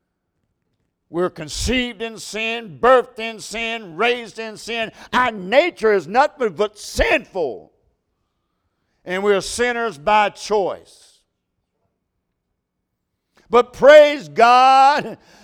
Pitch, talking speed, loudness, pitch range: 225 Hz, 95 wpm, -17 LUFS, 210-245 Hz